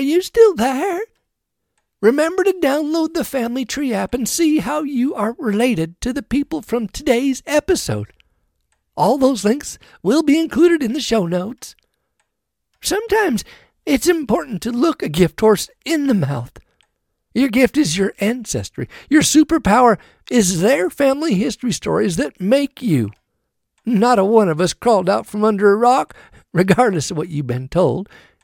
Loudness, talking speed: -17 LUFS, 160 wpm